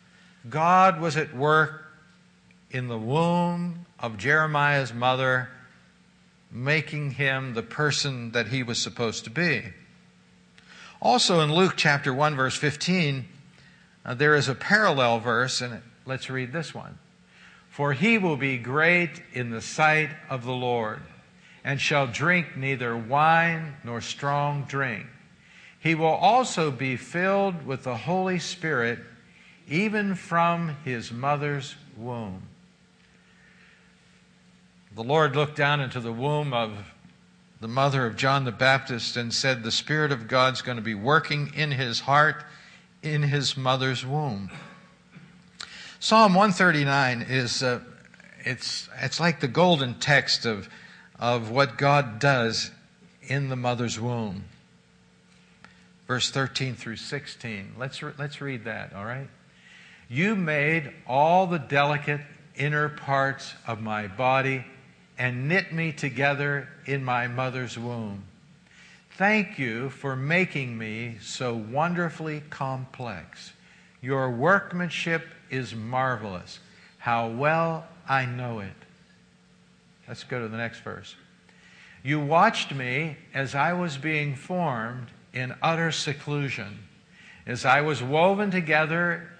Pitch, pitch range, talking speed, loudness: 140 Hz, 125-160 Hz, 125 wpm, -25 LUFS